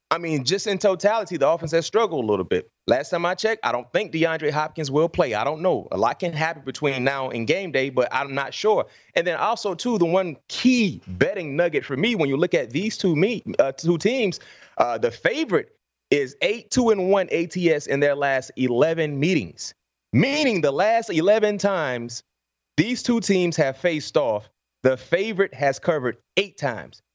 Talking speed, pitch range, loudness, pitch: 195 wpm, 140-215 Hz, -22 LUFS, 170 Hz